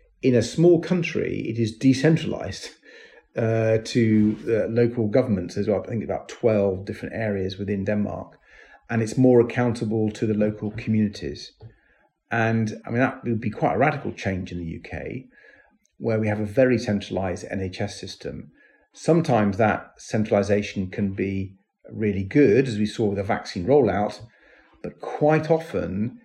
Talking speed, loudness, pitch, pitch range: 155 wpm, -23 LUFS, 110 Hz, 100-120 Hz